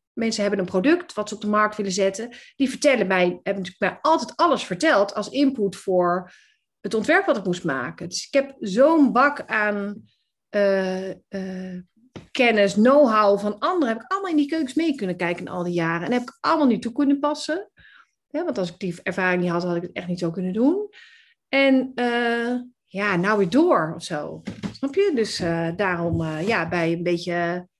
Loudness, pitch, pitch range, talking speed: -22 LUFS, 210 Hz, 185-275 Hz, 205 wpm